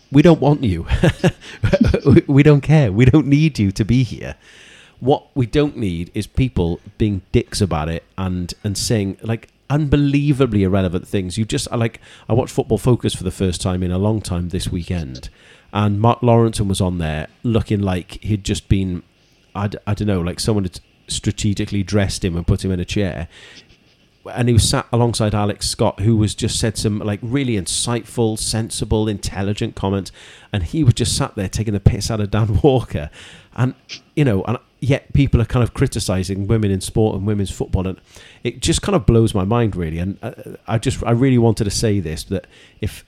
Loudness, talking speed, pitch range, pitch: -18 LUFS, 195 wpm, 95-120 Hz, 105 Hz